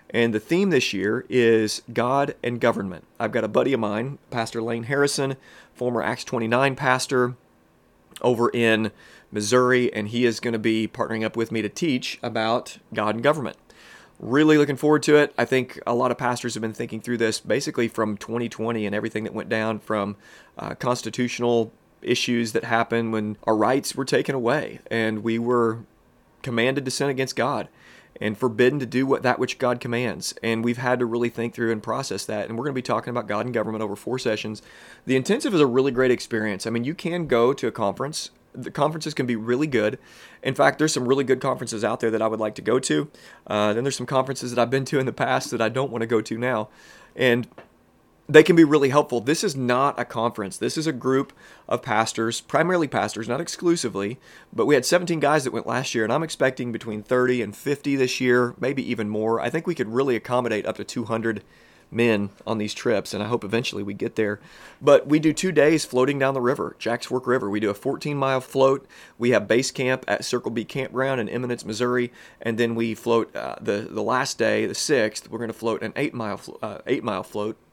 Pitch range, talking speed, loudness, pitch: 110-130 Hz, 220 wpm, -23 LUFS, 120 Hz